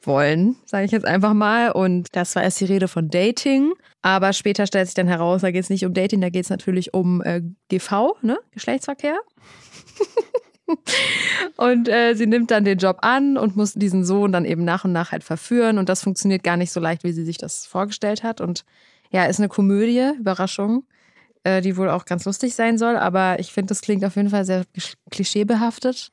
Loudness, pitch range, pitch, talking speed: -20 LUFS, 185-230 Hz, 200 Hz, 210 wpm